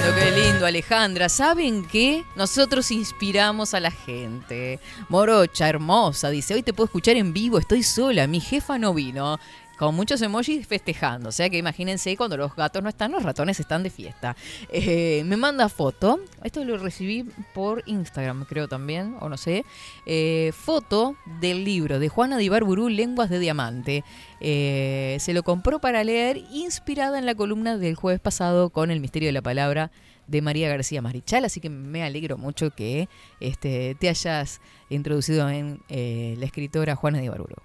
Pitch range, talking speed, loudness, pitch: 145-215 Hz, 170 wpm, -24 LUFS, 175 Hz